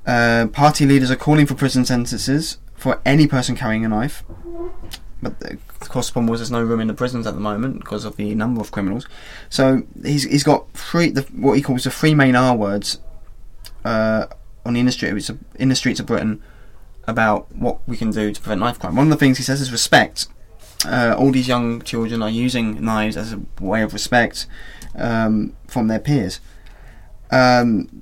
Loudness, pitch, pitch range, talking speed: -18 LUFS, 120 Hz, 110-135 Hz, 195 wpm